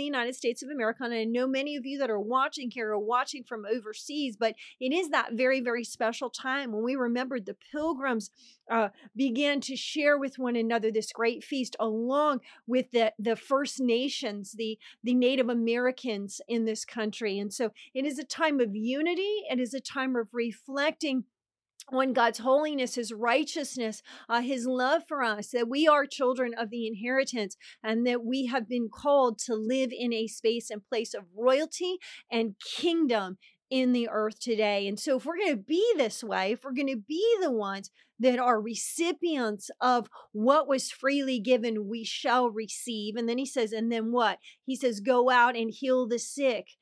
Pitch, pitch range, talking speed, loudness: 245 Hz, 225-270 Hz, 190 wpm, -29 LUFS